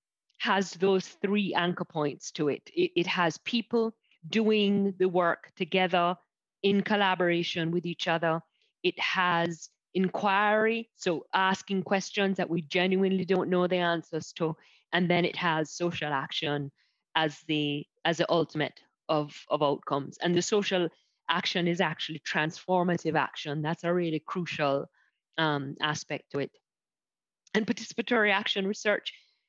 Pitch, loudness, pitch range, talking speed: 175 Hz, -29 LUFS, 160-195 Hz, 140 wpm